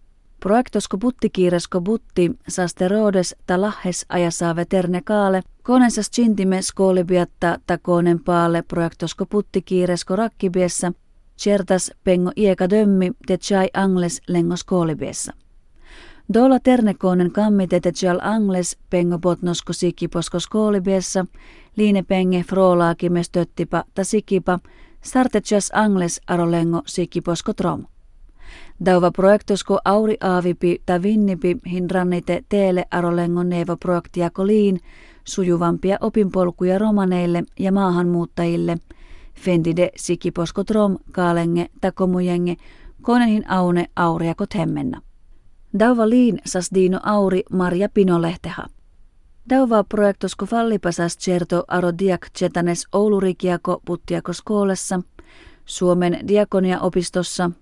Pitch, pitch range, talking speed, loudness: 185 Hz, 175-200 Hz, 95 wpm, -19 LUFS